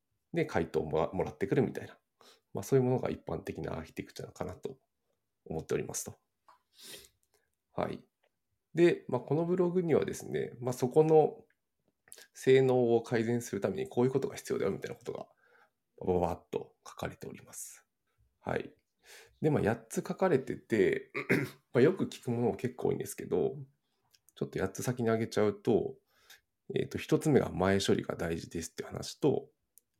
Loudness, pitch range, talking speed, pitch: -32 LUFS, 115-155 Hz, 340 characters per minute, 130 Hz